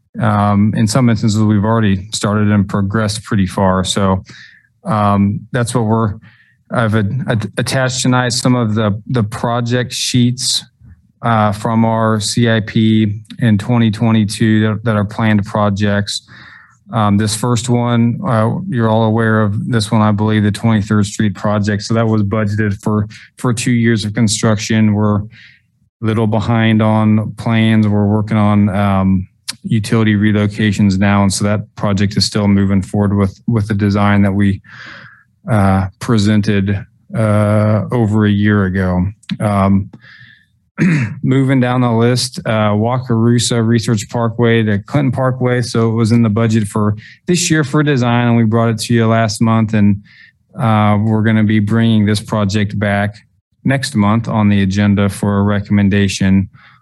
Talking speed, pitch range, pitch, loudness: 155 wpm, 105-115 Hz, 110 Hz, -14 LUFS